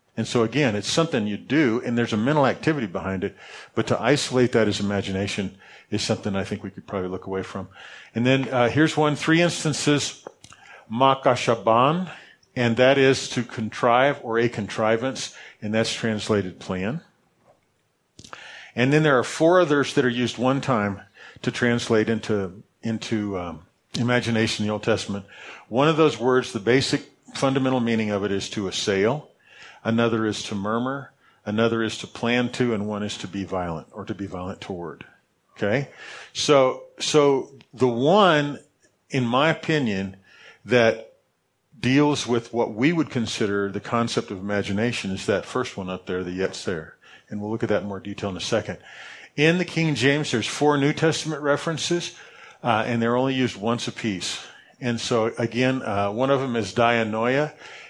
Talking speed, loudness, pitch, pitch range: 175 wpm, -23 LUFS, 115 Hz, 105-135 Hz